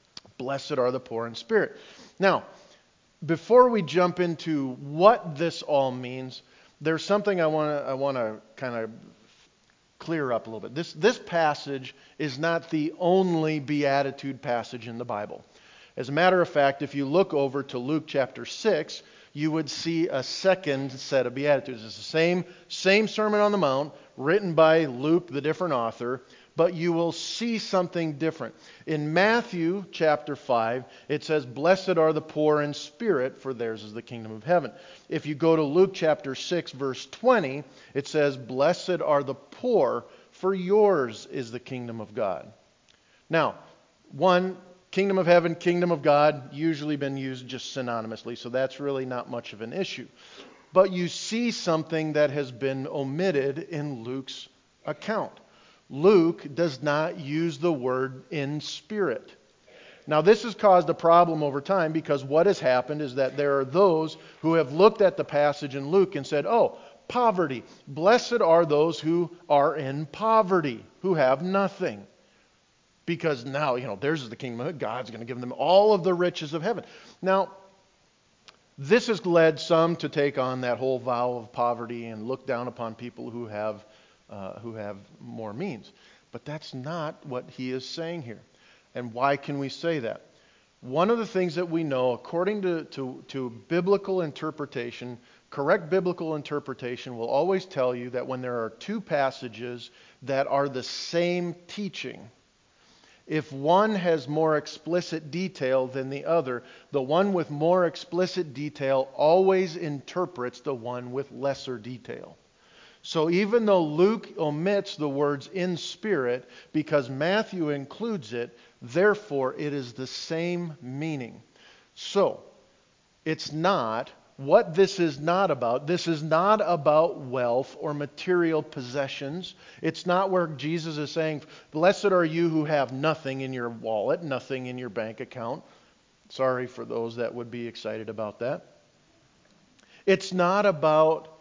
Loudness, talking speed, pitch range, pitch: -26 LUFS, 160 wpm, 130-175 Hz, 150 Hz